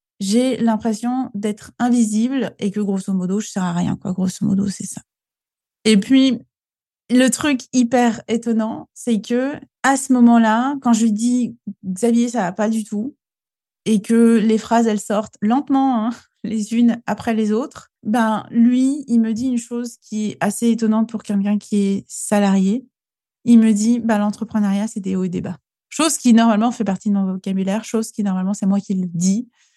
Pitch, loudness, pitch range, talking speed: 220 Hz, -18 LUFS, 205-240 Hz, 190 wpm